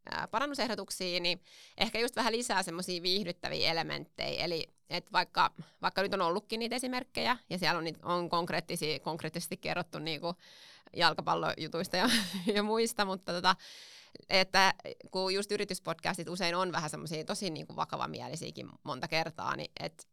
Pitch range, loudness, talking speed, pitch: 170-205 Hz, -33 LUFS, 140 wpm, 185 Hz